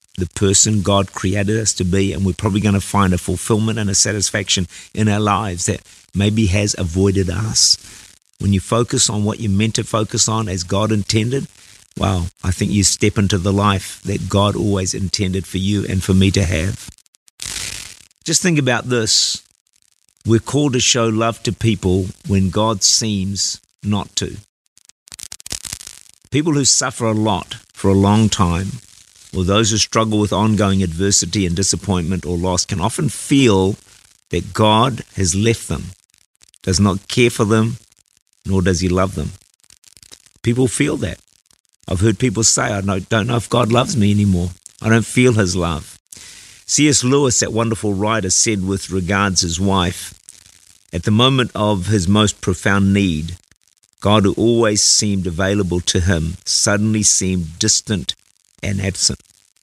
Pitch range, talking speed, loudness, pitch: 95-110 Hz, 165 wpm, -16 LUFS, 100 Hz